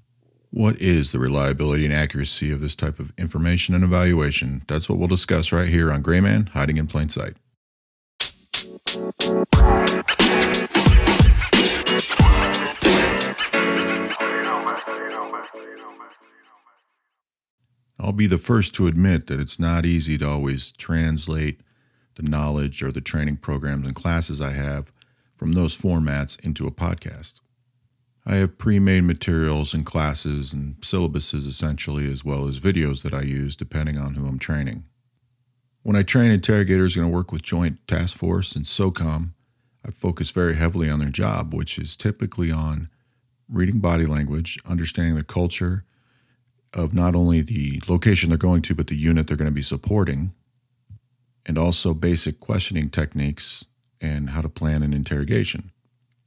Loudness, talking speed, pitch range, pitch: -21 LUFS, 145 wpm, 75-100 Hz, 85 Hz